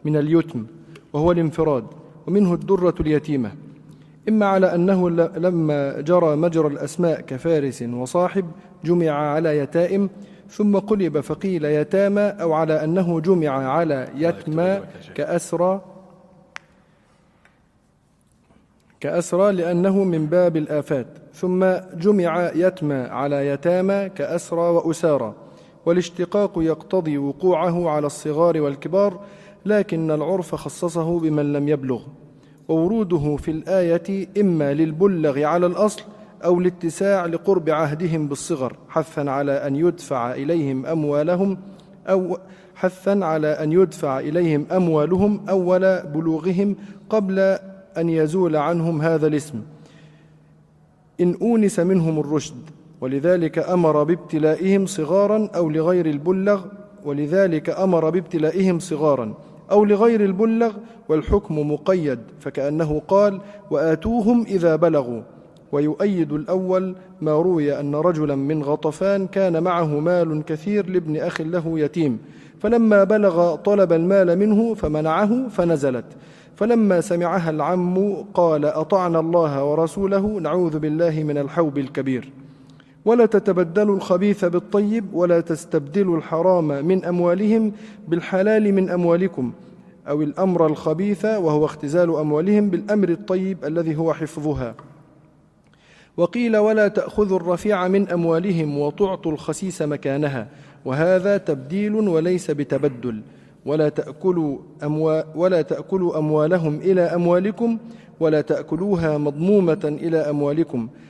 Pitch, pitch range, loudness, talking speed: 170 Hz, 155-190 Hz, -20 LUFS, 105 wpm